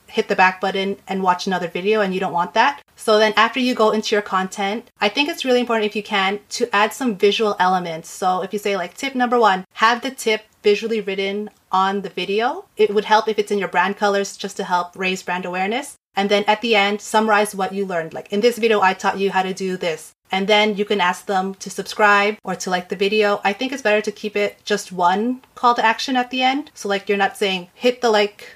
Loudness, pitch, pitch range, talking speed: -19 LUFS, 205 Hz, 190-220 Hz, 255 wpm